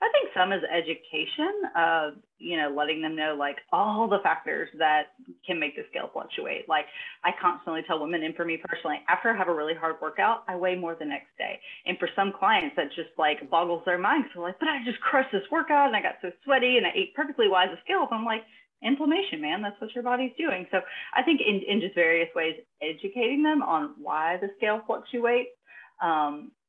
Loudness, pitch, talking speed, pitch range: -27 LUFS, 195 Hz, 220 wpm, 165-260 Hz